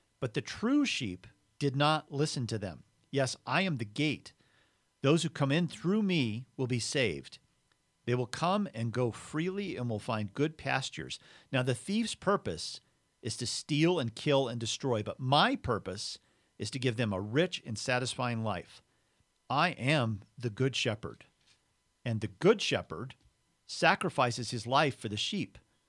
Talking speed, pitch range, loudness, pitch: 165 wpm, 115-150 Hz, -32 LUFS, 125 Hz